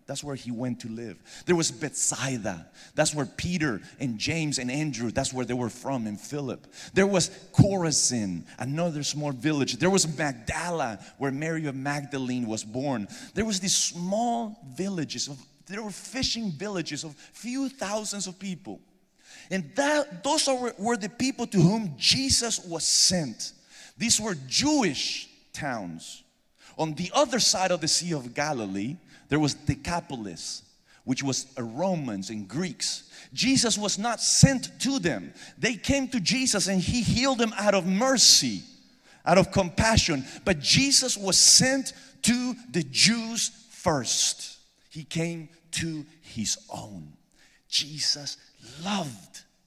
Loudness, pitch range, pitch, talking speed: -25 LUFS, 140-210 Hz, 170 Hz, 145 wpm